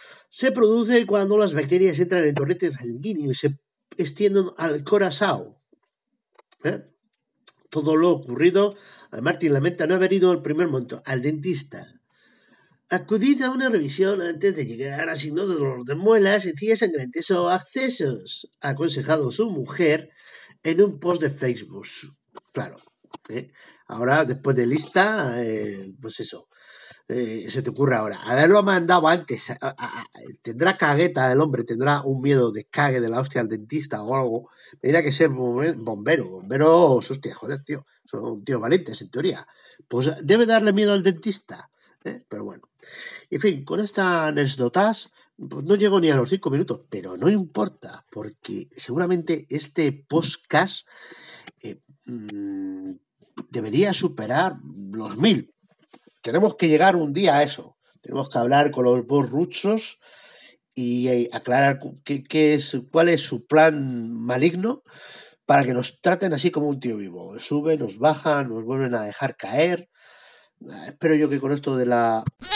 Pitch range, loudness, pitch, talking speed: 130-185 Hz, -22 LUFS, 155 Hz, 155 wpm